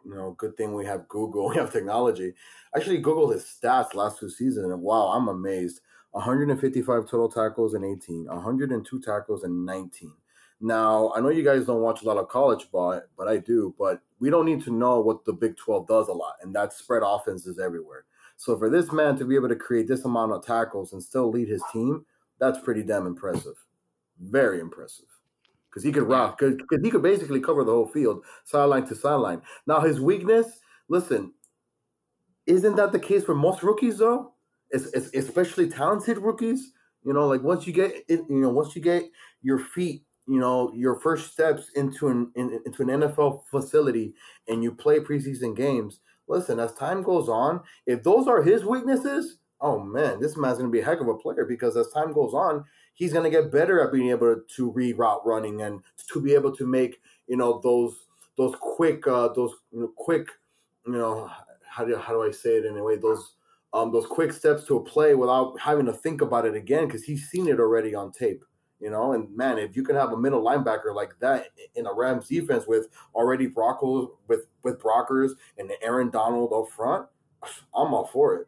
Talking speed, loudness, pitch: 200 wpm, -25 LUFS, 135 Hz